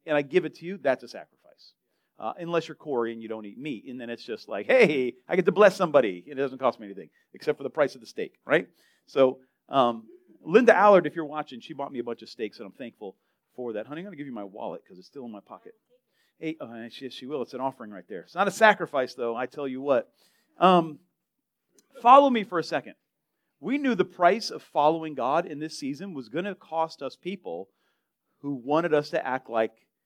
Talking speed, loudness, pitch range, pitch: 240 wpm, -25 LUFS, 130-185 Hz, 155 Hz